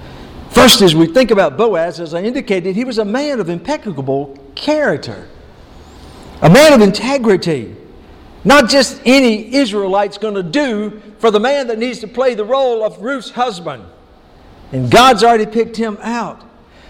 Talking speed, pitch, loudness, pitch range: 160 wpm, 220 Hz, -12 LUFS, 195-255 Hz